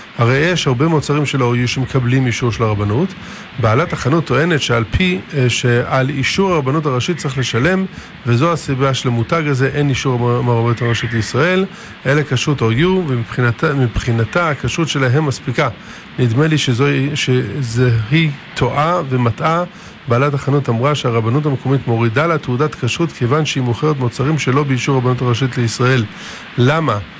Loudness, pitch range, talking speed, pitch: -16 LUFS, 120-150 Hz, 140 wpm, 130 Hz